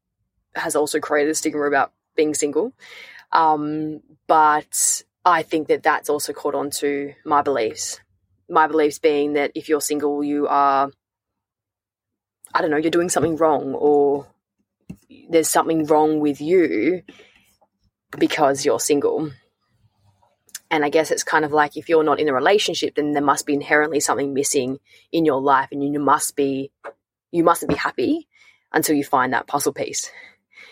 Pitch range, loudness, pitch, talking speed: 140-160 Hz, -20 LUFS, 150 Hz, 160 wpm